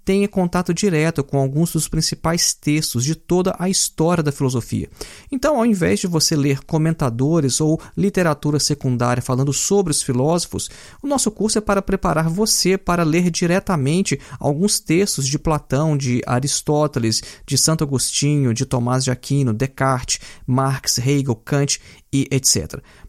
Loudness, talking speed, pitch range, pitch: -19 LUFS, 150 wpm, 135-175 Hz, 150 Hz